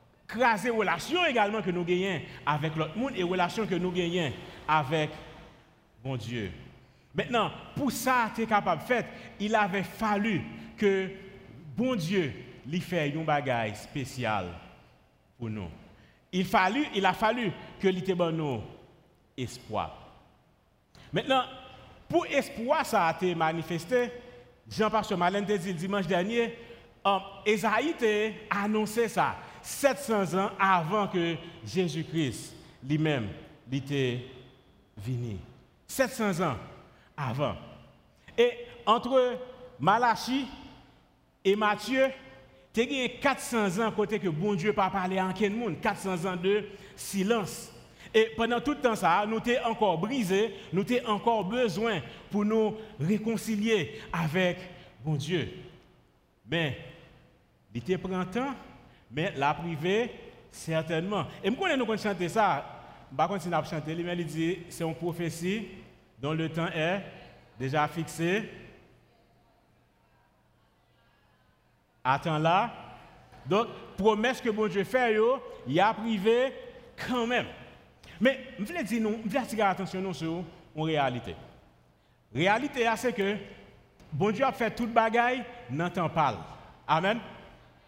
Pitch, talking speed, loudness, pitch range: 195 Hz, 125 wpm, -29 LUFS, 160-225 Hz